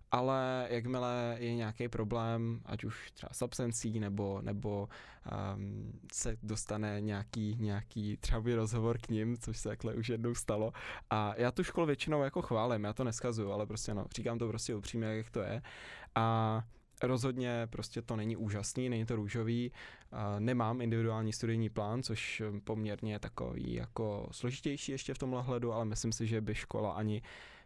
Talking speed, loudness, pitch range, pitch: 170 wpm, -37 LUFS, 105-120 Hz, 115 Hz